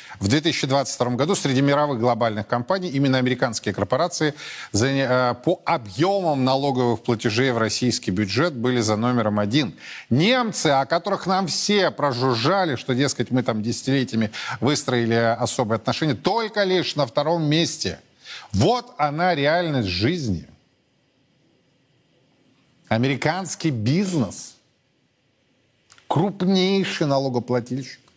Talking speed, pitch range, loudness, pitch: 100 wpm, 120-165 Hz, -22 LUFS, 135 Hz